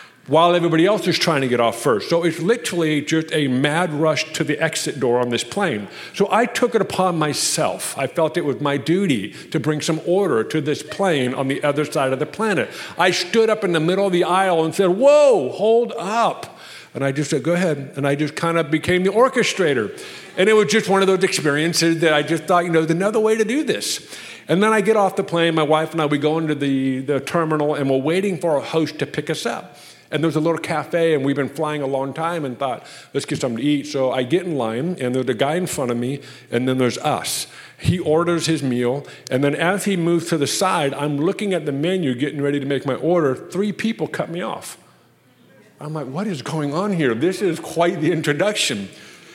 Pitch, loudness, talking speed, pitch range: 160 Hz, -19 LUFS, 245 wpm, 145-180 Hz